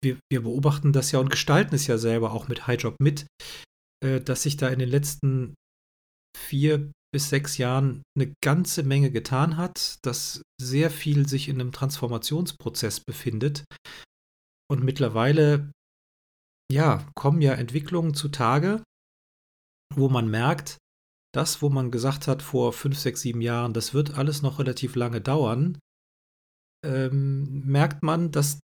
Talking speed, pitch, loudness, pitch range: 140 wpm, 140 Hz, -25 LUFS, 125-145 Hz